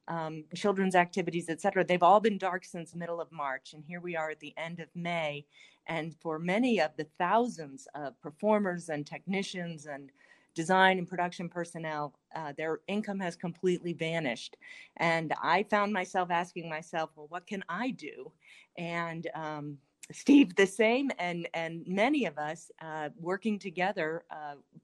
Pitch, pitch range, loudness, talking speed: 170 Hz, 160-190 Hz, -31 LUFS, 165 wpm